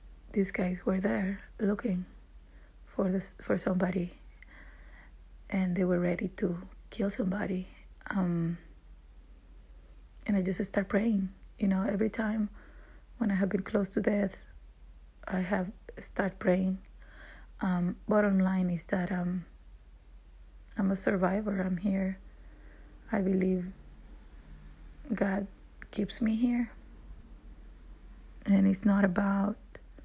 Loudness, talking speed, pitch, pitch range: -31 LUFS, 115 wpm, 190 Hz, 175-200 Hz